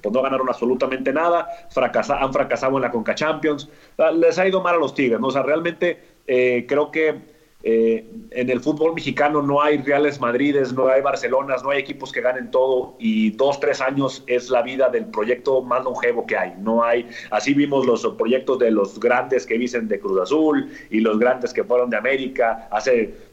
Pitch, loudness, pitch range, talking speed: 135 Hz, -20 LUFS, 125-155 Hz, 205 wpm